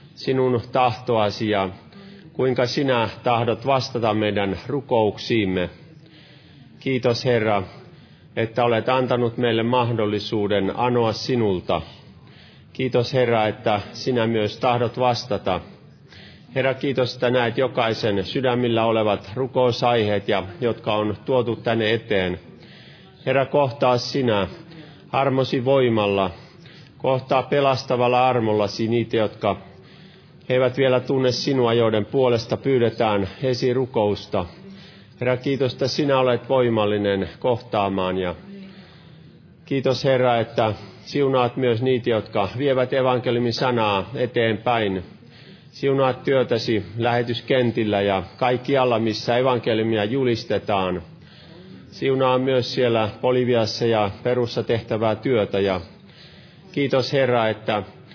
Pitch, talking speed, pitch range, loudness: 120 Hz, 100 wpm, 110-130 Hz, -21 LUFS